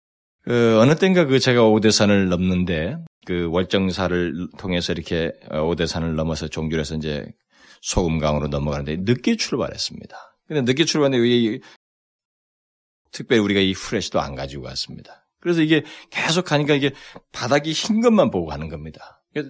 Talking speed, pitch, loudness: 340 characters per minute, 90 Hz, -20 LUFS